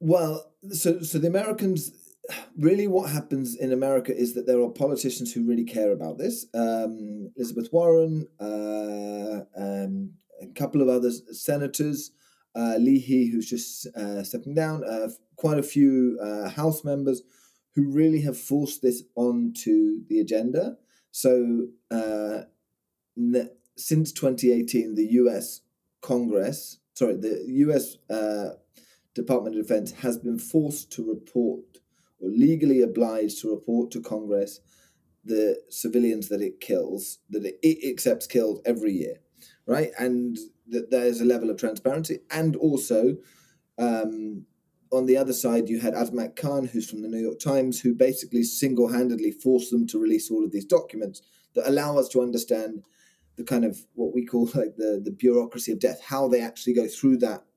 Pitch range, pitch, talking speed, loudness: 115-145 Hz, 125 Hz, 155 wpm, -25 LUFS